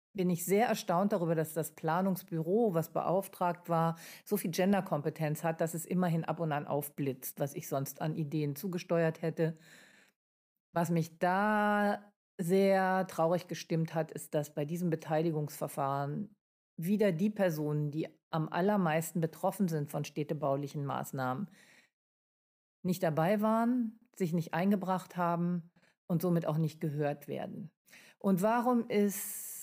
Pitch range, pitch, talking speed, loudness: 160-195 Hz, 170 Hz, 140 wpm, -33 LUFS